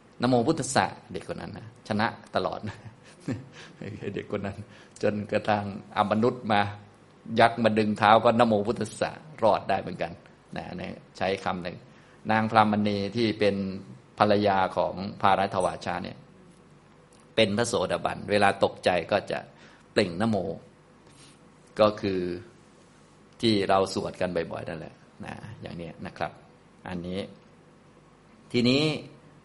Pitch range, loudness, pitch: 100-115 Hz, -27 LUFS, 105 Hz